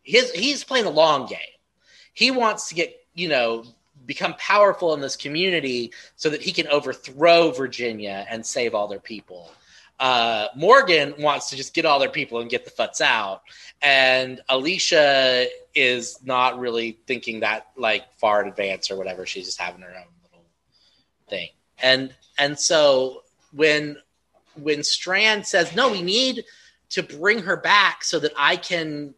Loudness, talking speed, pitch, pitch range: -20 LUFS, 165 wpm, 140 Hz, 120-170 Hz